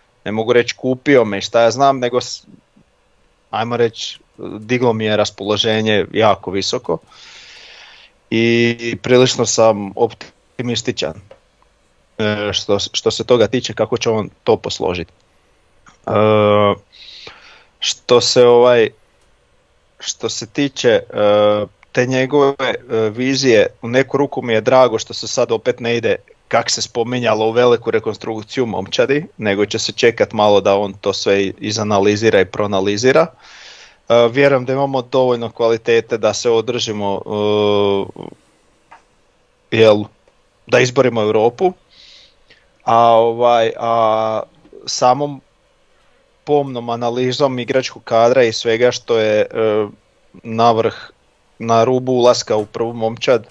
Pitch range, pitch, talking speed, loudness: 105-125 Hz, 115 Hz, 120 wpm, -15 LUFS